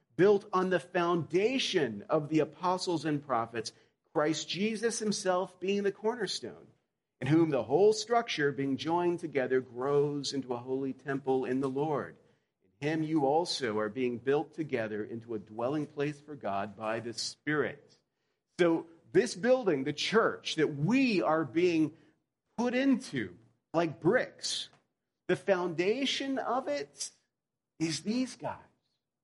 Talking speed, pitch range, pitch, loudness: 140 wpm, 135-190 Hz, 155 Hz, -31 LUFS